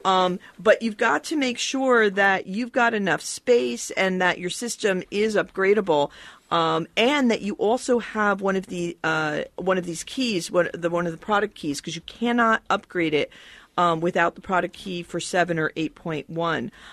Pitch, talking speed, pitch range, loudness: 190 Hz, 200 wpm, 170-220 Hz, -23 LUFS